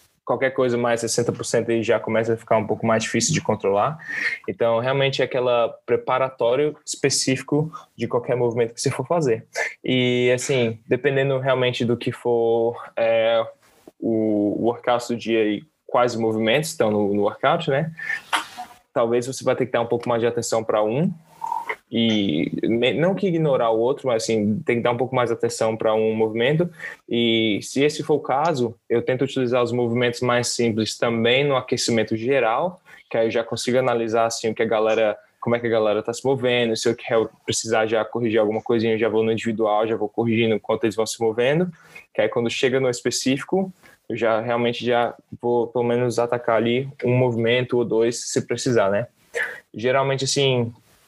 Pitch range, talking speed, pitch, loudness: 115-130 Hz, 190 wpm, 120 Hz, -22 LUFS